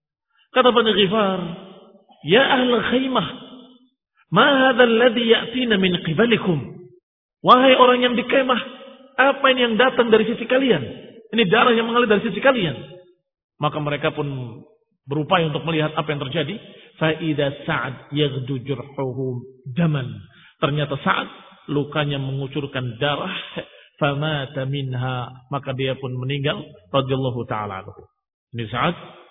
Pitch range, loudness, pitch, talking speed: 140-235 Hz, -20 LUFS, 175 Hz, 125 wpm